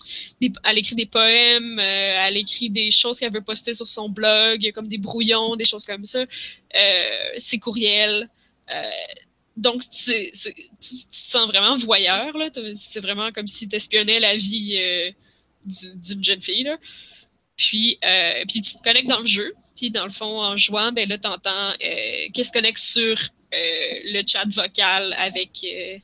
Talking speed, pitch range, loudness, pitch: 185 wpm, 205-240 Hz, -17 LUFS, 220 Hz